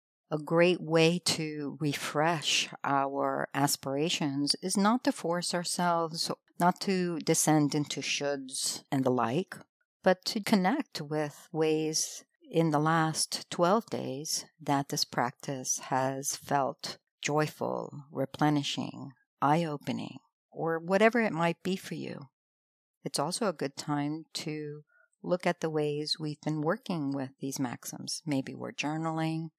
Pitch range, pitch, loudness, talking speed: 145-175 Hz, 155 Hz, -30 LUFS, 130 wpm